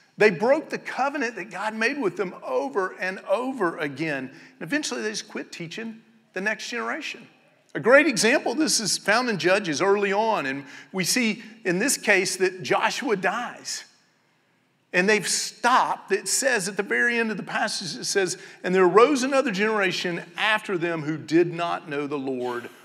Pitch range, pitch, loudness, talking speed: 185-235 Hz, 210 Hz, -23 LUFS, 180 wpm